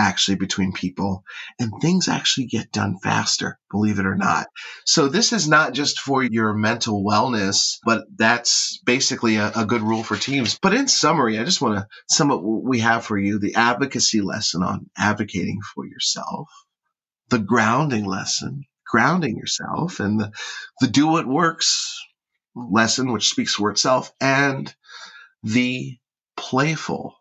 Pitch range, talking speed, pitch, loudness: 105-135 Hz, 155 wpm, 115 Hz, -20 LUFS